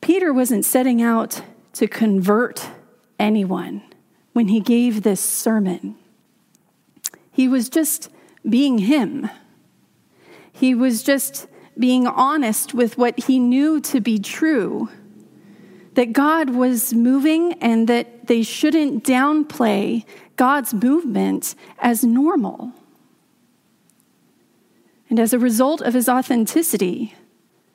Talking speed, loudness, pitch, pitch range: 105 wpm, -18 LUFS, 245 Hz, 225-275 Hz